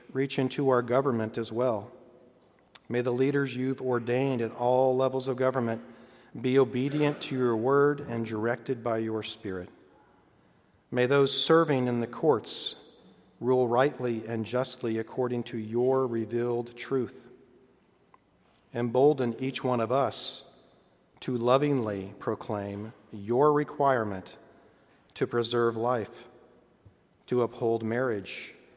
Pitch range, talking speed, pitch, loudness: 115-130 Hz, 120 wpm, 125 Hz, -28 LUFS